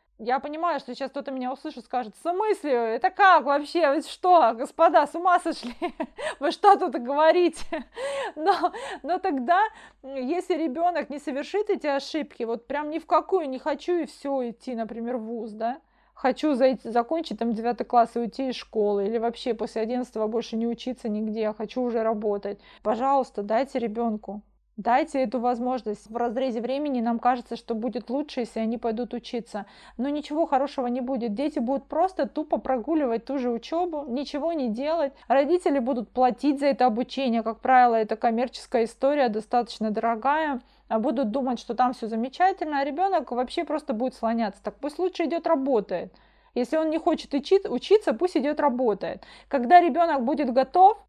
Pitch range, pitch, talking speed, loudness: 235-315 Hz, 265 Hz, 170 wpm, -25 LUFS